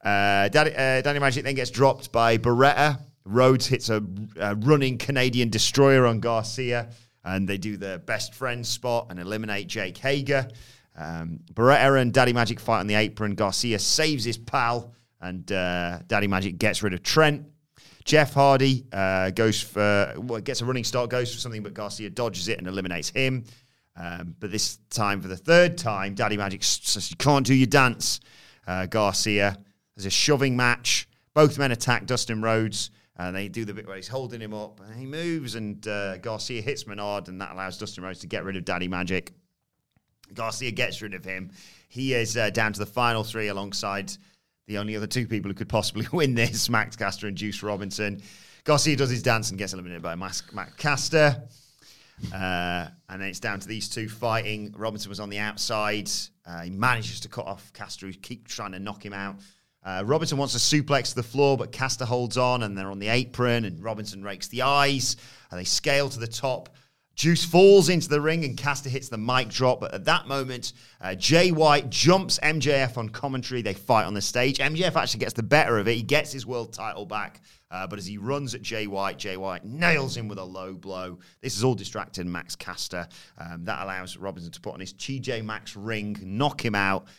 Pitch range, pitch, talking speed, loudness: 100-130 Hz, 115 Hz, 205 wpm, -25 LUFS